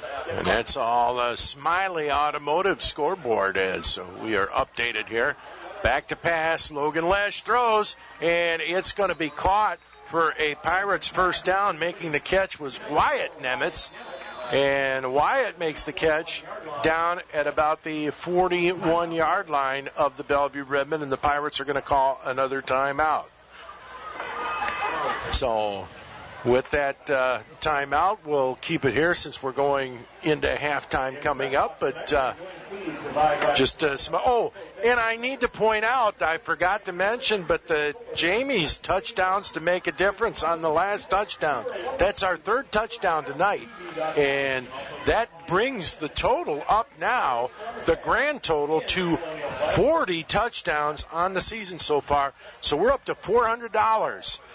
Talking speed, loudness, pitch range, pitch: 145 wpm, -24 LUFS, 140-185 Hz, 160 Hz